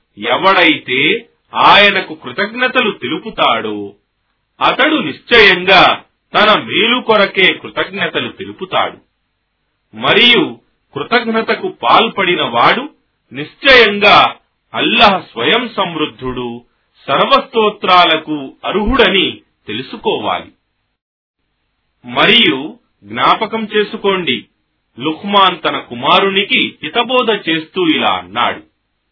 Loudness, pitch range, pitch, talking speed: -11 LUFS, 155-225 Hz, 195 Hz, 65 wpm